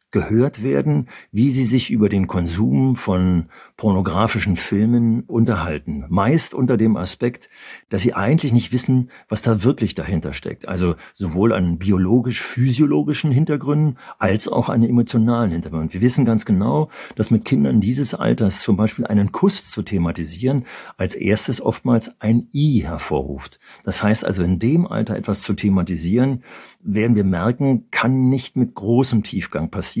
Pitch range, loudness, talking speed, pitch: 95-130 Hz, -19 LUFS, 150 wpm, 115 Hz